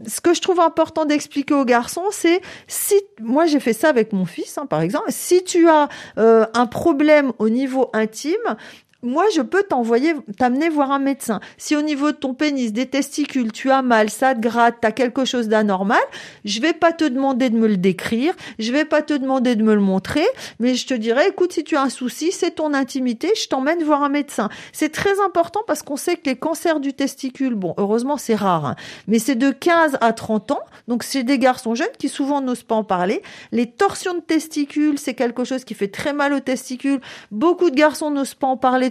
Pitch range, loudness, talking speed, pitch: 235-310 Hz, -19 LUFS, 225 wpm, 275 Hz